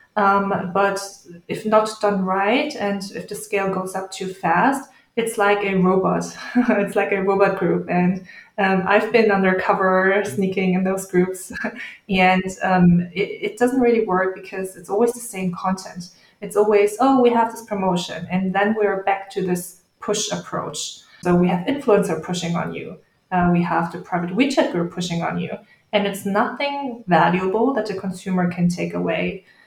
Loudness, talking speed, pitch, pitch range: -20 LUFS, 175 wpm, 195 Hz, 185-210 Hz